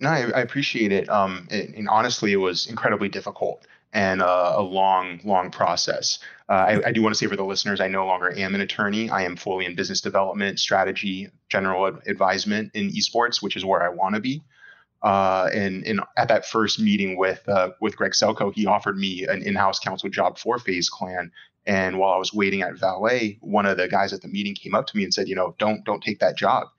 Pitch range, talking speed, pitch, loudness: 95-110 Hz, 230 wpm, 100 Hz, -23 LUFS